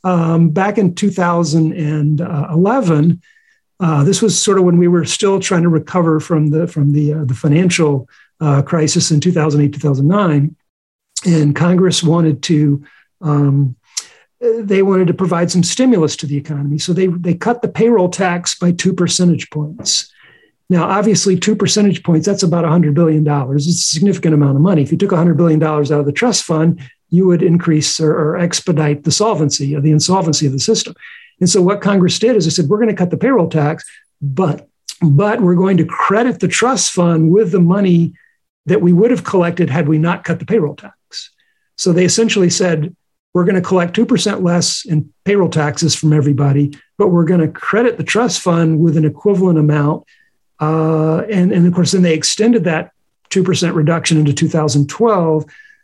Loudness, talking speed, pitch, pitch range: -13 LUFS, 185 wpm, 170 Hz, 155-195 Hz